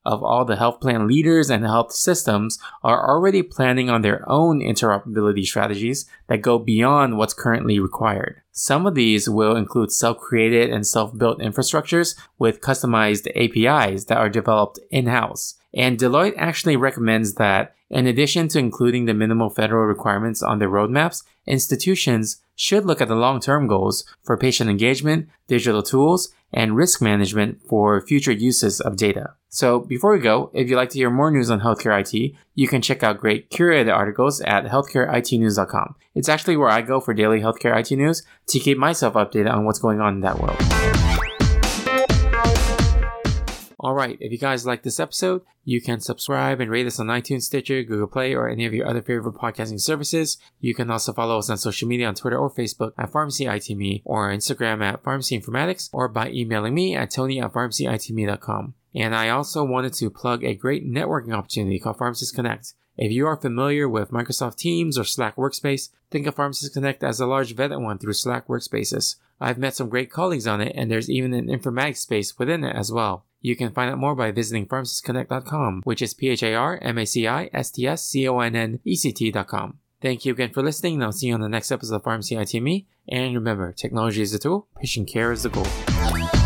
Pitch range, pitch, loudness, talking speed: 110-135 Hz, 120 Hz, -21 LUFS, 185 wpm